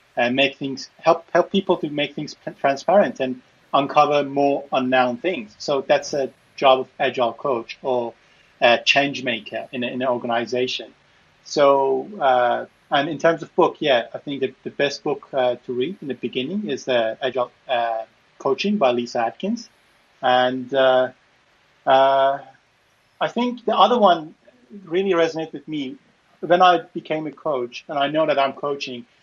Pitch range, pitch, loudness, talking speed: 125-160 Hz, 140 Hz, -21 LUFS, 170 wpm